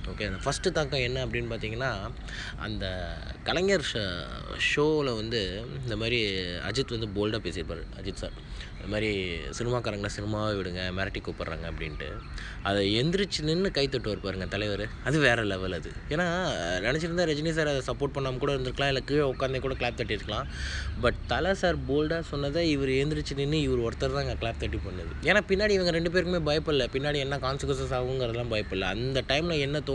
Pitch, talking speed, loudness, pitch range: 120 Hz, 165 wpm, -29 LUFS, 100-140 Hz